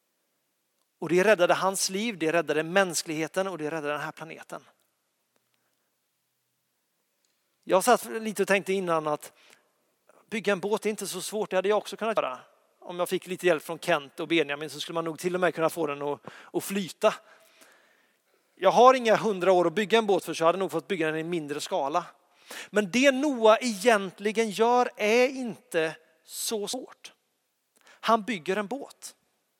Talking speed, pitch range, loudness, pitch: 180 wpm, 165-215 Hz, -26 LUFS, 190 Hz